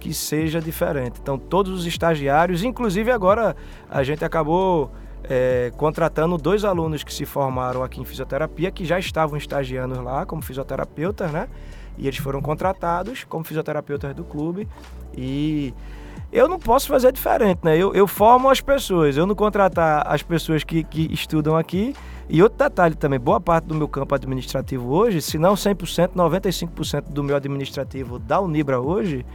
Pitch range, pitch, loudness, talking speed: 140-185 Hz, 160 Hz, -21 LUFS, 165 wpm